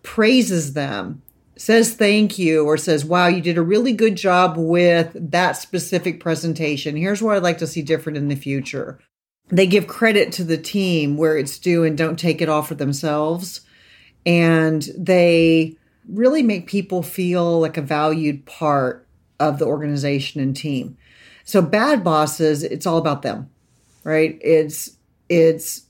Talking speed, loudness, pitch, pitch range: 160 wpm, -18 LUFS, 165 Hz, 155-180 Hz